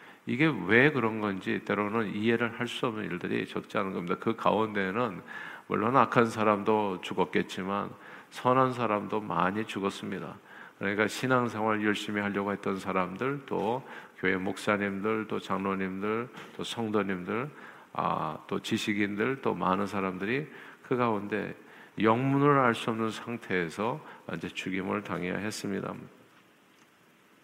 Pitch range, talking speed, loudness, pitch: 100-115 Hz, 290 characters per minute, -30 LUFS, 105 Hz